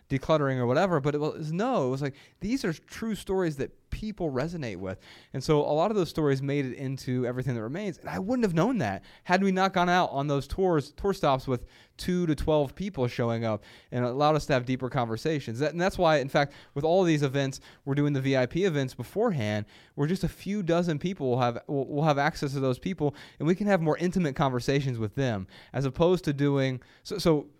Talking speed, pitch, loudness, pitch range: 235 wpm, 145 Hz, -28 LUFS, 130-175 Hz